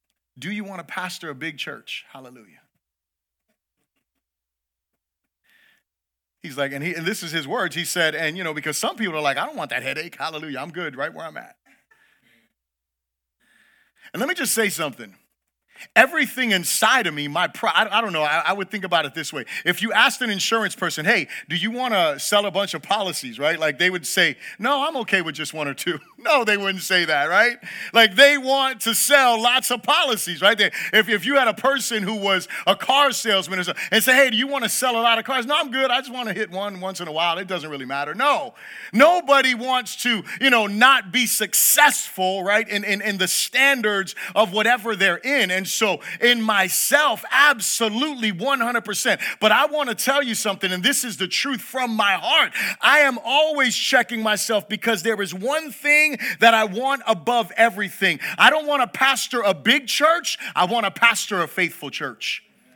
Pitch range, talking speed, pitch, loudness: 185-255 Hz, 210 wpm, 215 Hz, -19 LUFS